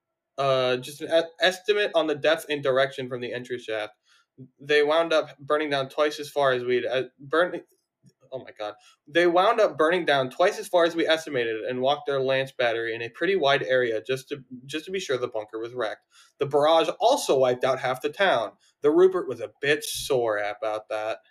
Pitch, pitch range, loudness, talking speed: 140 Hz, 125-165 Hz, -25 LUFS, 210 wpm